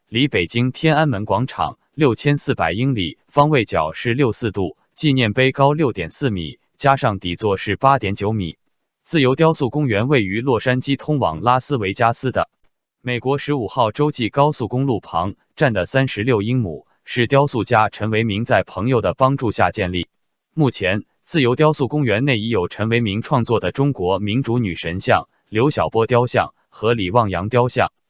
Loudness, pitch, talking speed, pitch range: -19 LUFS, 125 Hz, 270 characters per minute, 110-140 Hz